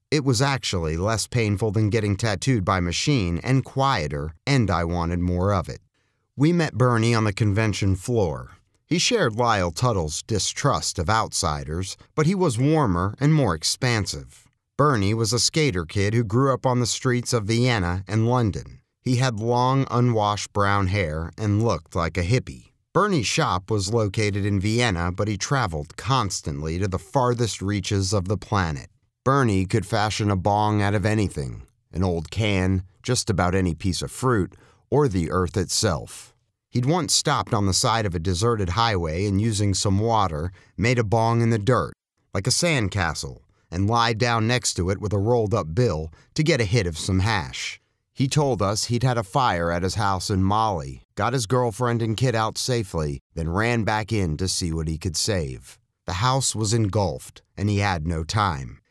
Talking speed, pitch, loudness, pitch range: 185 wpm, 105 Hz, -23 LUFS, 95-120 Hz